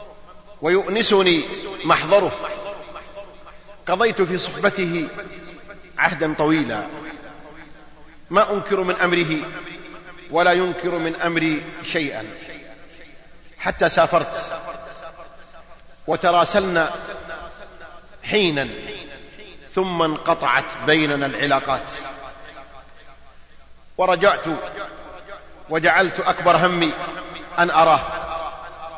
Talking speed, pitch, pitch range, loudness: 60 wpm, 170 Hz, 155-185 Hz, -20 LUFS